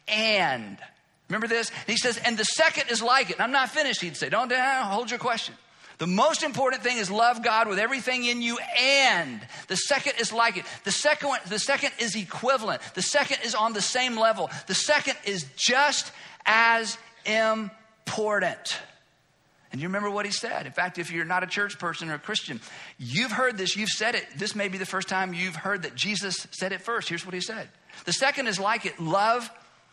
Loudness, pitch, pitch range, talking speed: -25 LUFS, 220 Hz, 190-245 Hz, 210 wpm